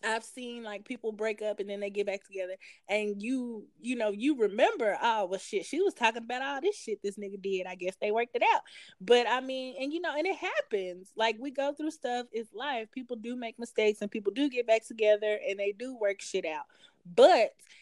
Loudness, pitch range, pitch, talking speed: -31 LUFS, 205-265 Hz, 225 Hz, 235 wpm